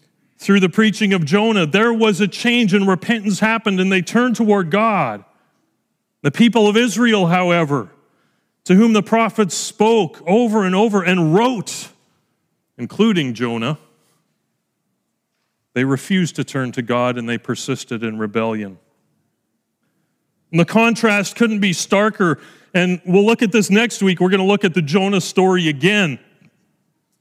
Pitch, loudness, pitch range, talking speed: 195 Hz, -16 LUFS, 165-215 Hz, 150 wpm